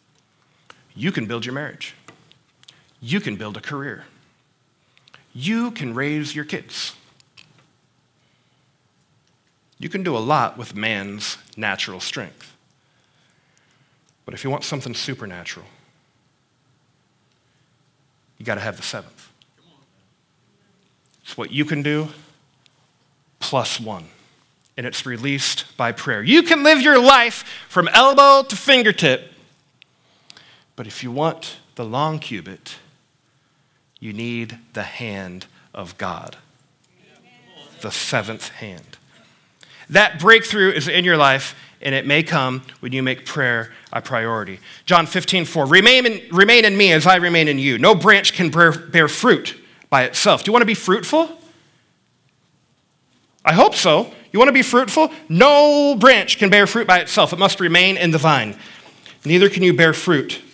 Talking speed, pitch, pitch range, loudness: 140 wpm, 155 Hz, 130-200 Hz, -15 LUFS